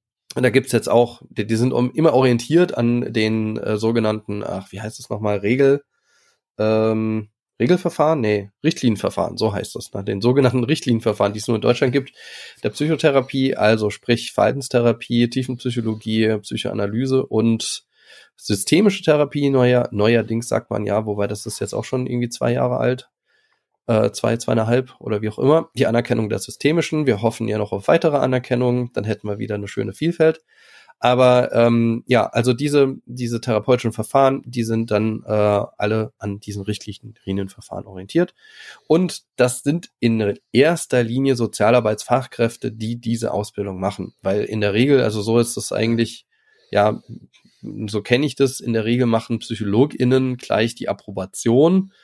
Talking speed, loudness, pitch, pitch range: 160 wpm, -20 LUFS, 120 Hz, 110-130 Hz